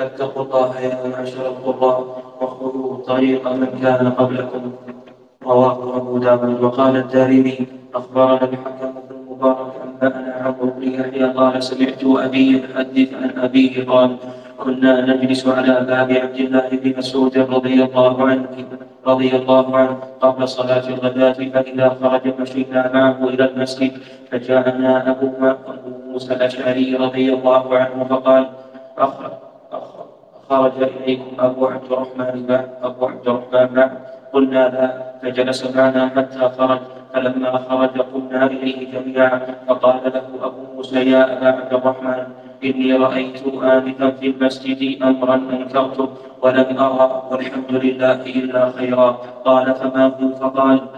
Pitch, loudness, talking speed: 130 Hz, -17 LUFS, 125 wpm